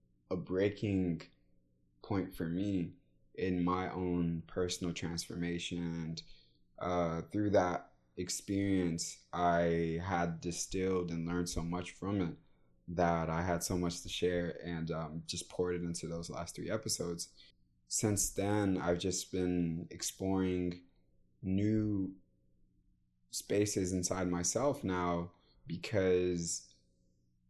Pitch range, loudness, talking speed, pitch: 80-95 Hz, -36 LUFS, 115 wpm, 85 Hz